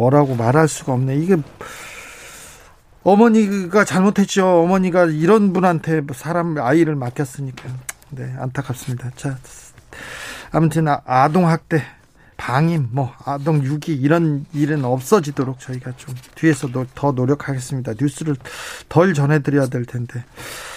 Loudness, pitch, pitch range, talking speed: -18 LUFS, 145 Hz, 130-165 Hz, 280 characters per minute